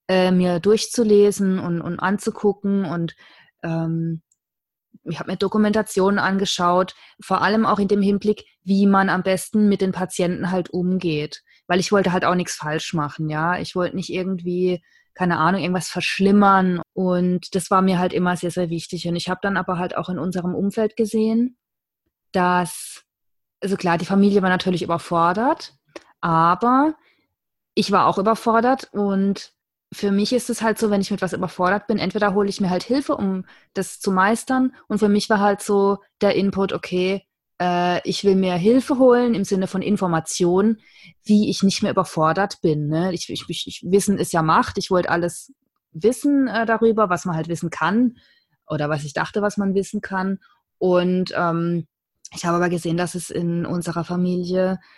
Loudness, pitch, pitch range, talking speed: -20 LUFS, 185 Hz, 175-205 Hz, 180 wpm